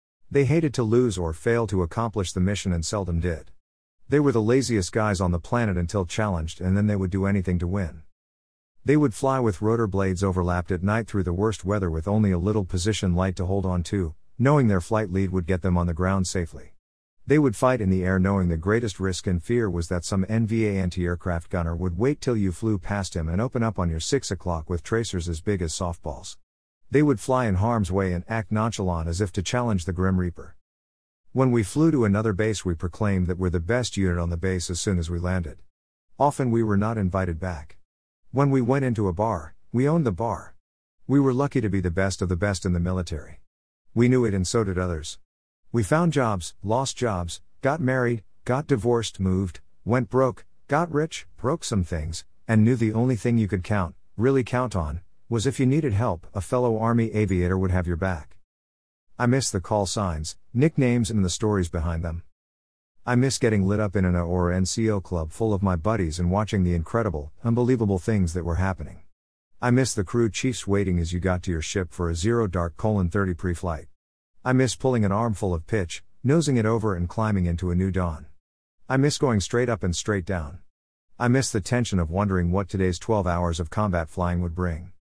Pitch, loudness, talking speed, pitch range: 95 Hz, -24 LUFS, 220 wpm, 90-115 Hz